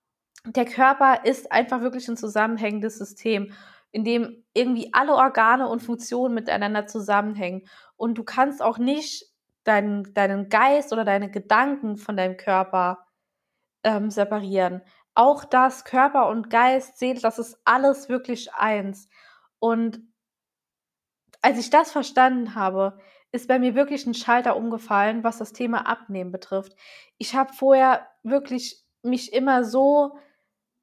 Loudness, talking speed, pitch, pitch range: -22 LUFS, 135 wpm, 230 Hz, 205-255 Hz